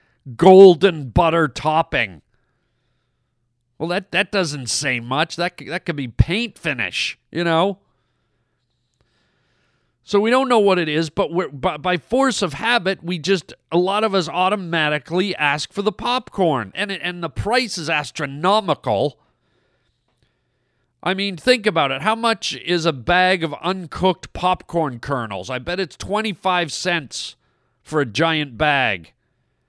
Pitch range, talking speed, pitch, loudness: 145-195 Hz, 145 wpm, 175 Hz, -19 LUFS